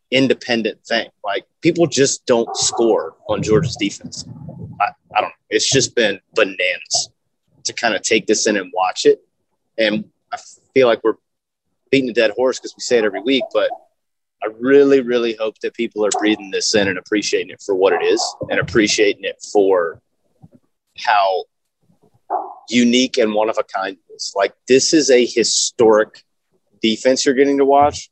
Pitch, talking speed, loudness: 140 Hz, 175 wpm, -17 LUFS